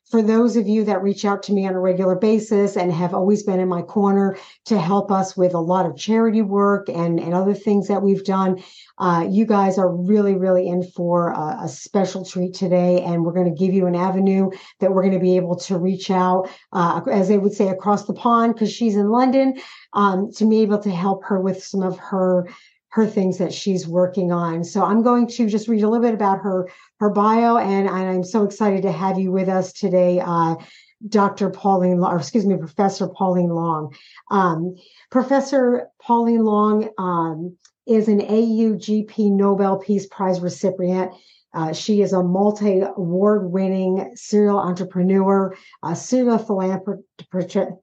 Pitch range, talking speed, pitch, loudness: 185-210 Hz, 190 wpm, 195 Hz, -19 LUFS